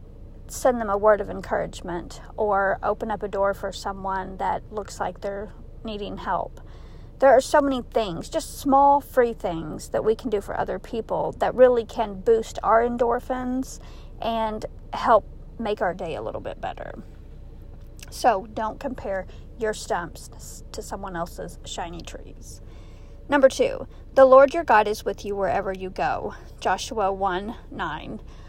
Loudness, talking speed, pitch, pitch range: -24 LUFS, 160 wpm, 220 Hz, 200-260 Hz